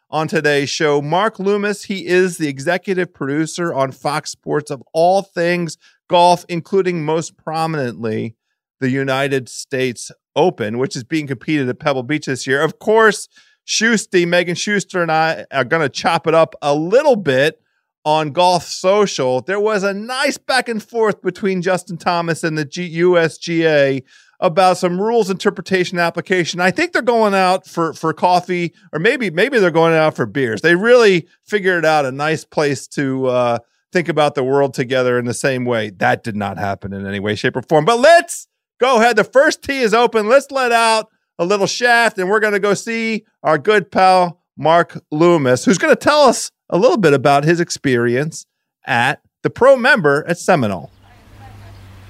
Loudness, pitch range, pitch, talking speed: -16 LUFS, 140-195 Hz, 170 Hz, 180 wpm